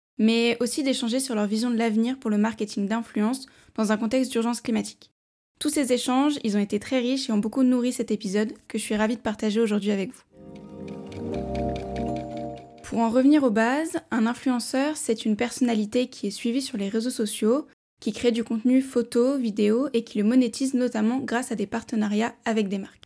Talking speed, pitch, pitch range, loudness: 195 wpm, 230 Hz, 215-250 Hz, -25 LUFS